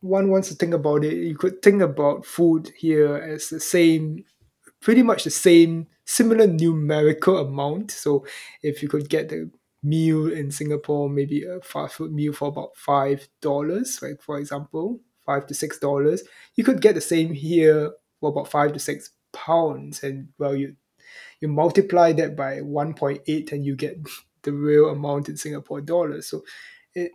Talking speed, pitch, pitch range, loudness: 175 wpm, 155 Hz, 145-170 Hz, -22 LUFS